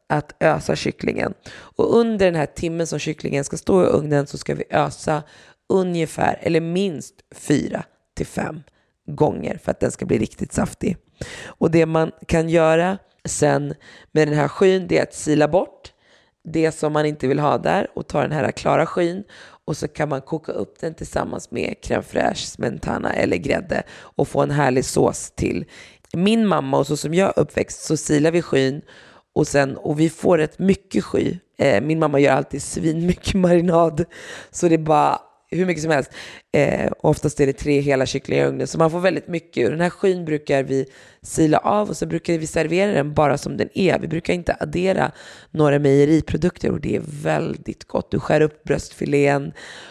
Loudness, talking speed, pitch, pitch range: -20 LUFS, 190 wpm, 160 Hz, 145-175 Hz